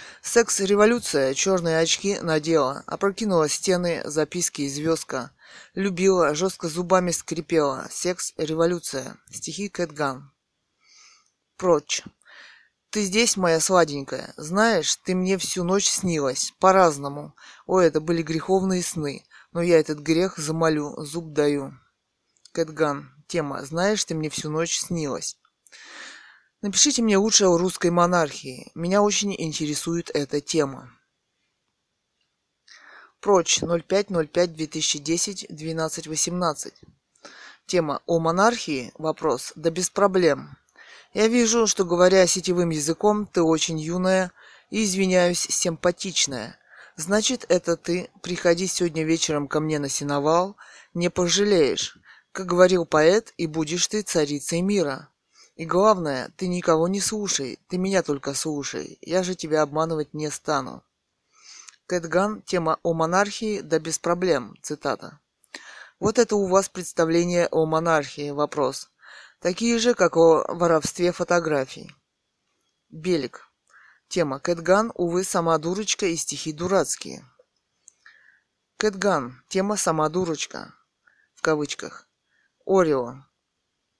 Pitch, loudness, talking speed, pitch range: 170 Hz, -23 LUFS, 110 wpm, 155-190 Hz